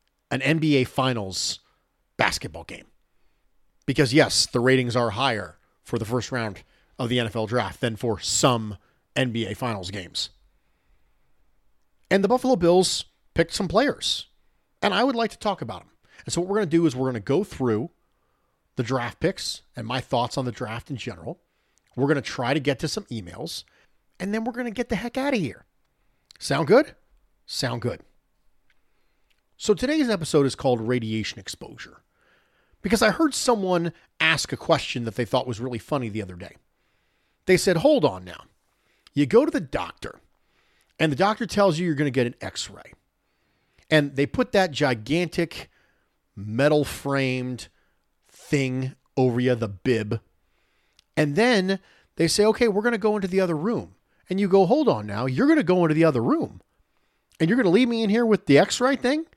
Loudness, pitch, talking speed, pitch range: -24 LUFS, 140 Hz, 185 wpm, 120-195 Hz